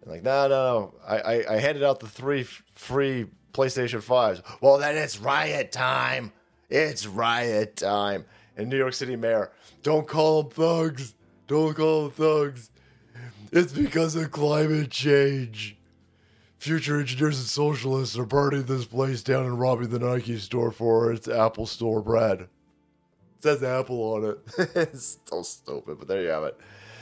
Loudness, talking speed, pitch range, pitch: -25 LUFS, 160 wpm, 115-150 Hz, 130 Hz